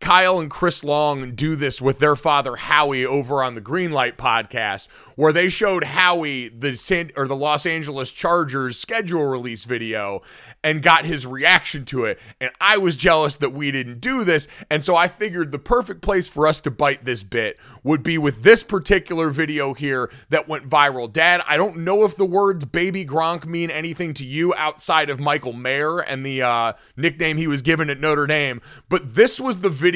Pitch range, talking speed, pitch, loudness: 135-175 Hz, 200 wpm, 155 Hz, -19 LUFS